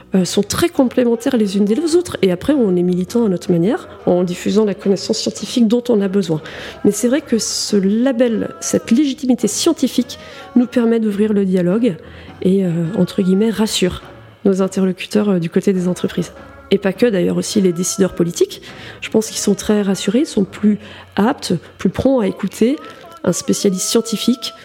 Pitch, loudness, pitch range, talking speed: 210 Hz, -16 LUFS, 190-240 Hz, 185 wpm